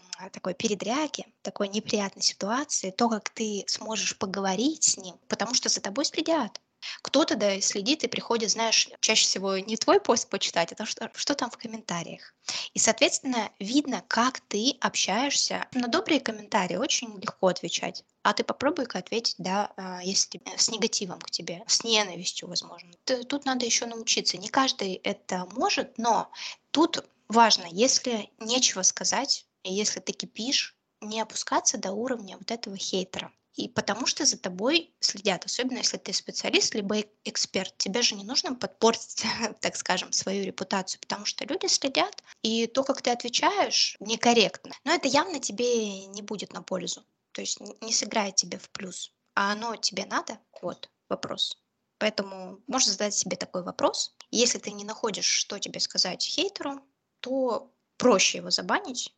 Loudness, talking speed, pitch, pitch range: -27 LUFS, 155 wpm, 225 Hz, 200-255 Hz